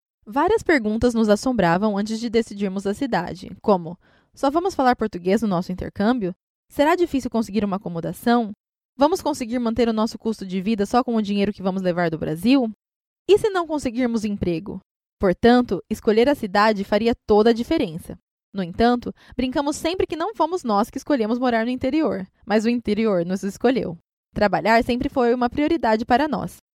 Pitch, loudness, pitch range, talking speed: 230 Hz, -21 LUFS, 205-260 Hz, 175 wpm